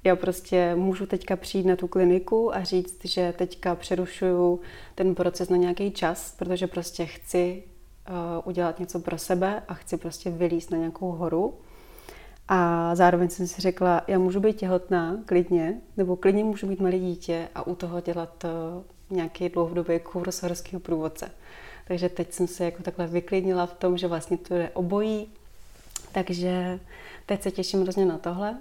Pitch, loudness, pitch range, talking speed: 180 Hz, -27 LUFS, 175-185 Hz, 170 wpm